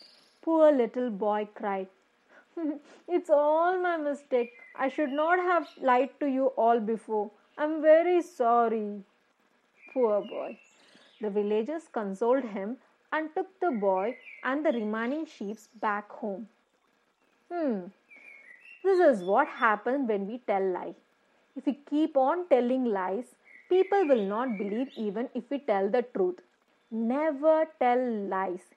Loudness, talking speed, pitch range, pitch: -28 LUFS, 135 wpm, 215-305 Hz, 250 Hz